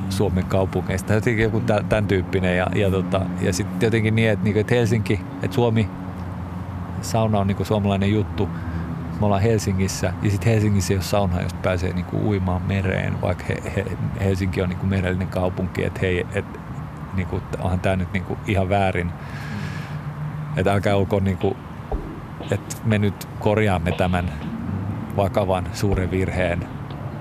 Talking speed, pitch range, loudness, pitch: 150 wpm, 90-105 Hz, -23 LUFS, 95 Hz